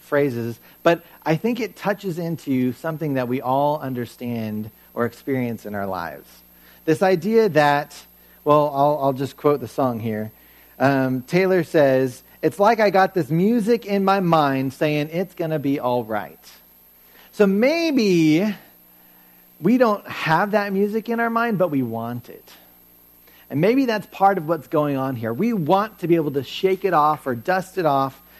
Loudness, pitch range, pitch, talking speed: -21 LUFS, 120-190 Hz, 145 Hz, 175 wpm